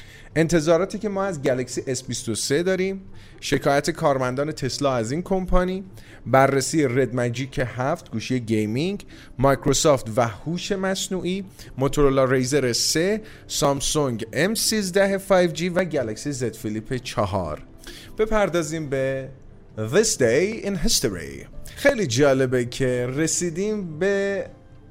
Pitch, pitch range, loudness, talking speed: 140 Hz, 125-180 Hz, -23 LUFS, 110 wpm